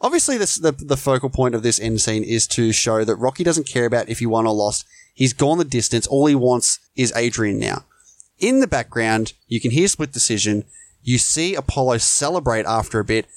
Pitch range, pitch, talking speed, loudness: 110-140 Hz, 120 Hz, 215 wpm, -19 LUFS